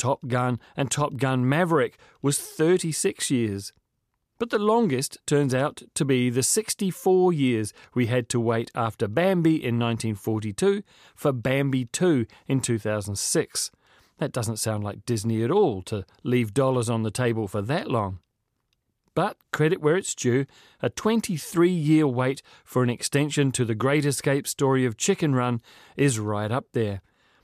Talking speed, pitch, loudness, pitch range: 155 wpm, 130 Hz, -25 LUFS, 115-150 Hz